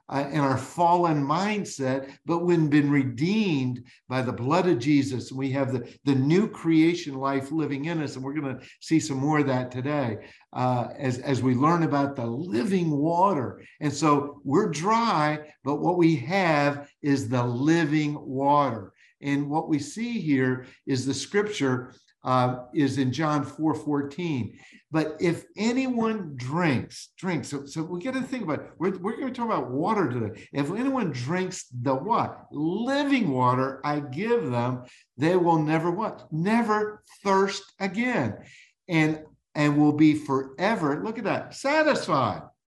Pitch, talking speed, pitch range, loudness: 150 Hz, 165 wpm, 135-175 Hz, -26 LUFS